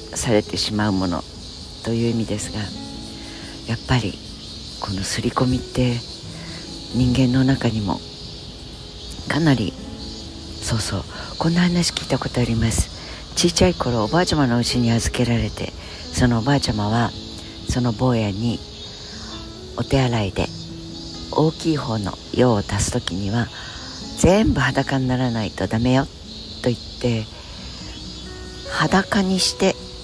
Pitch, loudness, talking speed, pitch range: 110 Hz, -21 LUFS, 250 characters per minute, 95-125 Hz